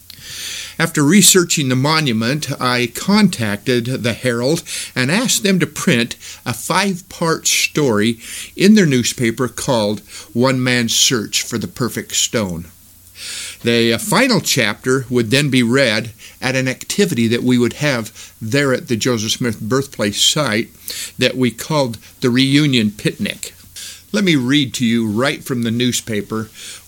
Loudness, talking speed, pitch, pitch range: -16 LUFS, 145 wpm, 125 Hz, 115-145 Hz